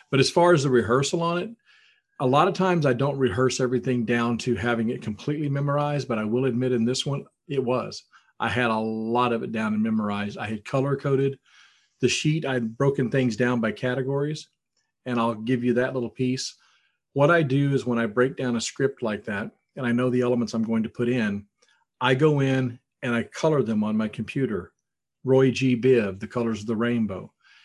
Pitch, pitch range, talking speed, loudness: 125 Hz, 115-140 Hz, 215 wpm, -24 LUFS